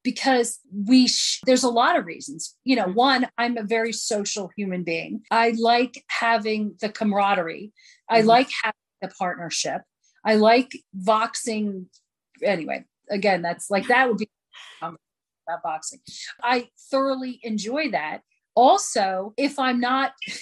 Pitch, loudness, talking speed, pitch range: 230 Hz, -22 LUFS, 140 wpm, 210-255 Hz